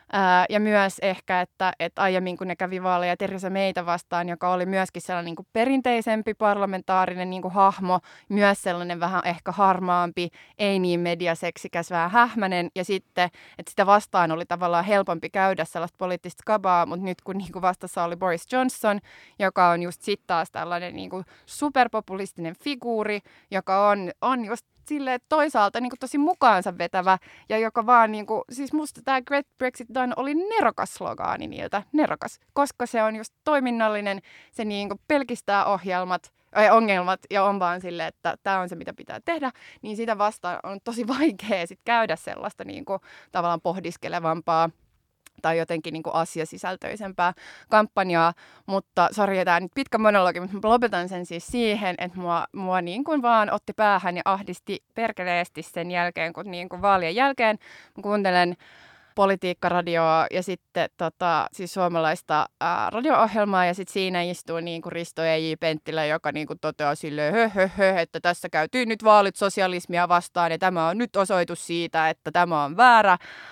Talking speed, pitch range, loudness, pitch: 165 wpm, 175-215 Hz, -24 LUFS, 185 Hz